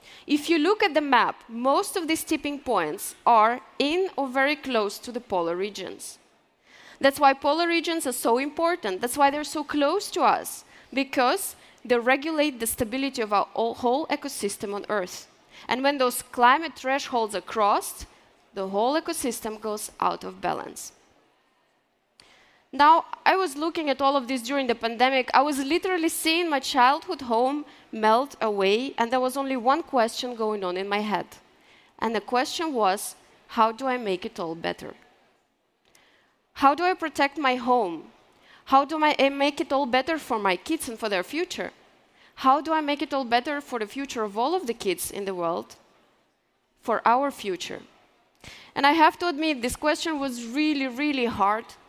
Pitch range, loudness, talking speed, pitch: 230-300 Hz, -25 LUFS, 175 wpm, 265 Hz